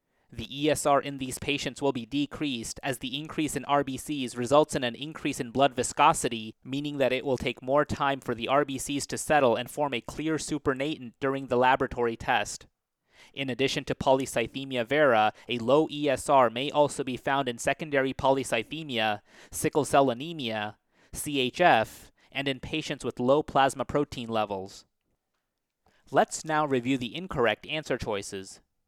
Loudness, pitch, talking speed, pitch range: -28 LUFS, 135 Hz, 155 wpm, 120-145 Hz